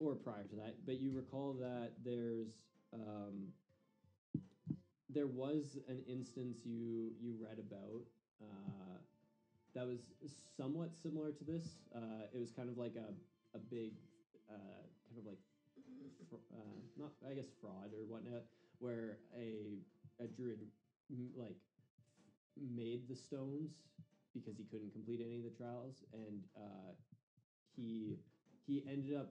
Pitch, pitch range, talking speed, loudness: 120 Hz, 110-135 Hz, 140 wpm, -50 LUFS